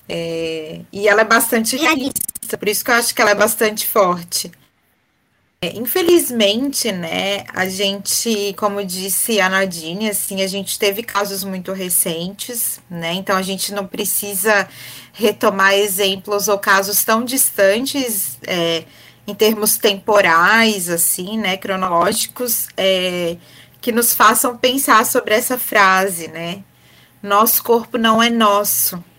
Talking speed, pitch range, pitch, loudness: 135 wpm, 190-225 Hz, 205 Hz, -16 LUFS